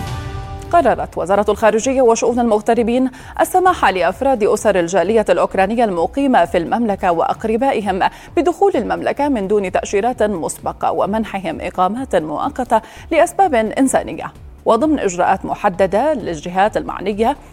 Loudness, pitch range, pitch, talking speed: -16 LUFS, 205-270 Hz, 230 Hz, 105 wpm